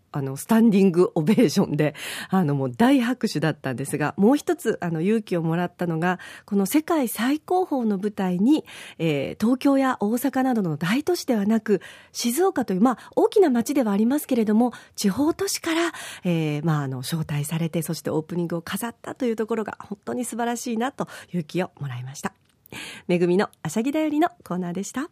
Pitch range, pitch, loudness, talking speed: 170-255 Hz, 205 Hz, -23 LUFS, 395 characters per minute